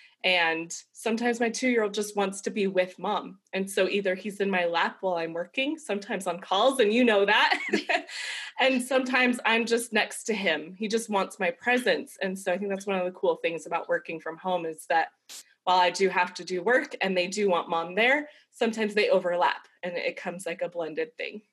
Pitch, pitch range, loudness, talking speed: 200 Hz, 180-230 Hz, -27 LUFS, 225 wpm